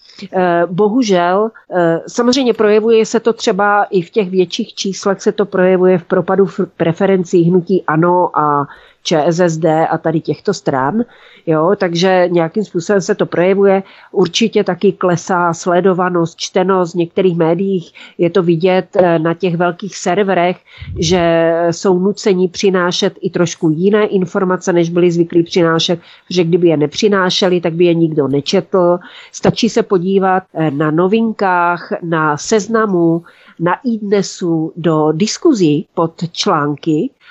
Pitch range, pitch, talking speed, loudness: 170-200 Hz, 185 Hz, 130 wpm, -14 LUFS